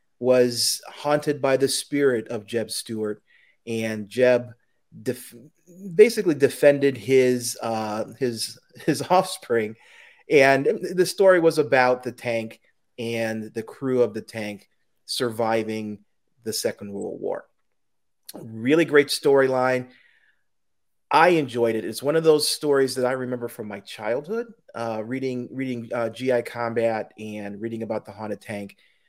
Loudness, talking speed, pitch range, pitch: -23 LUFS, 135 wpm, 115-140 Hz, 125 Hz